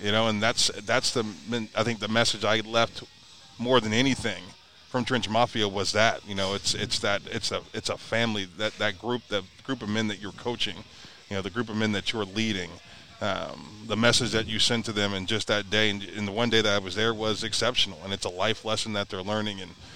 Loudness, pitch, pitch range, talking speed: -27 LUFS, 110 Hz, 100-115 Hz, 240 wpm